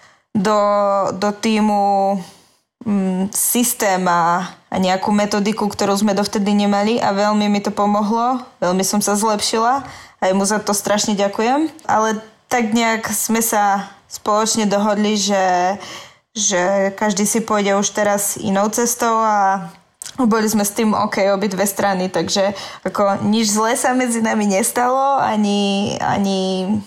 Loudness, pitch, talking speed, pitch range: -17 LUFS, 205 Hz, 140 wpm, 200-220 Hz